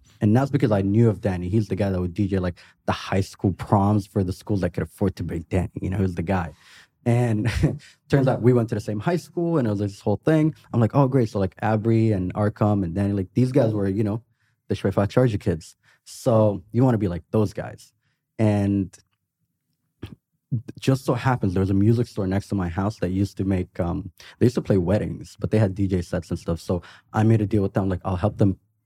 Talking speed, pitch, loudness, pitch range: 250 wpm, 105 Hz, -23 LUFS, 95-115 Hz